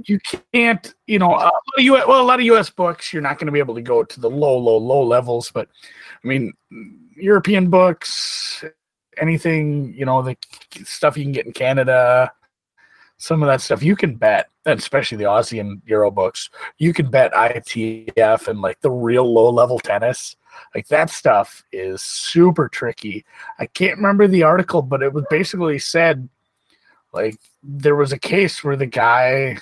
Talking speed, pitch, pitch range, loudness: 180 wpm, 150 Hz, 125-185 Hz, -17 LUFS